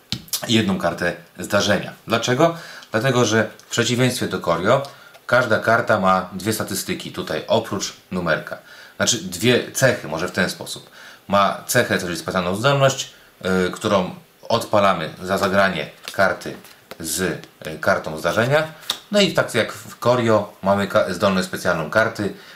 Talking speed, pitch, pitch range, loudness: 135 wpm, 105 Hz, 95-120 Hz, -20 LUFS